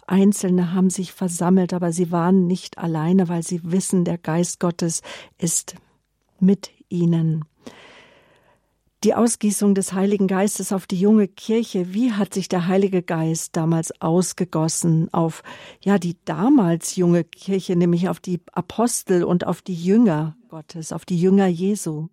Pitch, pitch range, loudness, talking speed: 185 Hz, 170-195 Hz, -20 LUFS, 145 wpm